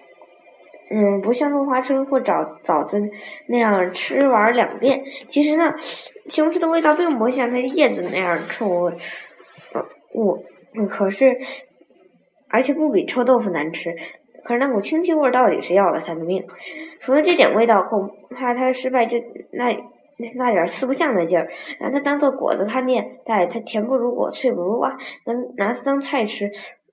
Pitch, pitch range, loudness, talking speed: 245 Hz, 205-275 Hz, -20 LUFS, 260 characters per minute